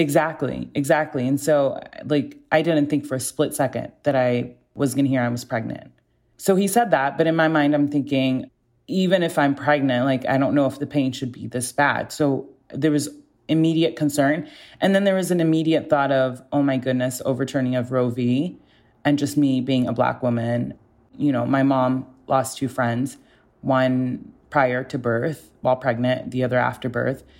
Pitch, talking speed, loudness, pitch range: 135 Hz, 195 wpm, -22 LUFS, 125-150 Hz